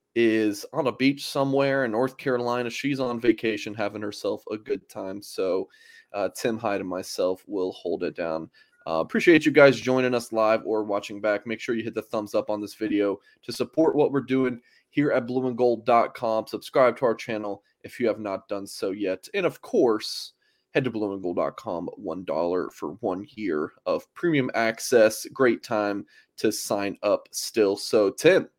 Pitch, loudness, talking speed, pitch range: 120 Hz, -25 LUFS, 180 wpm, 110-140 Hz